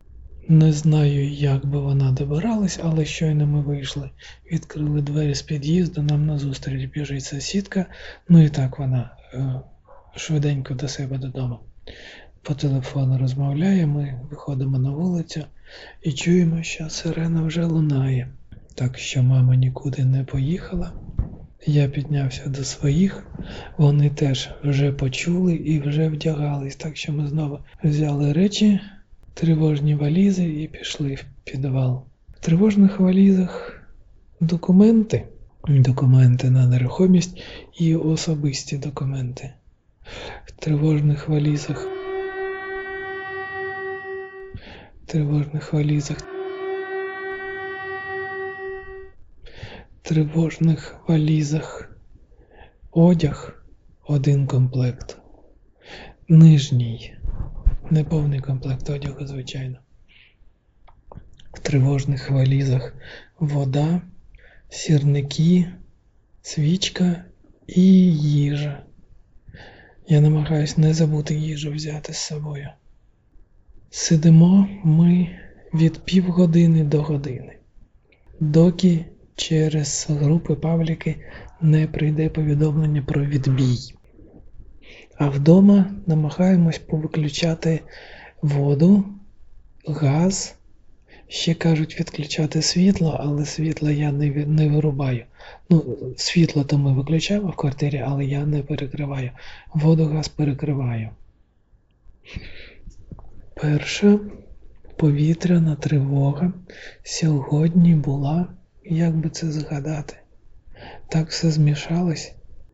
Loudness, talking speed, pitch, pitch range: -20 LUFS, 90 wpm, 150 Hz, 140-165 Hz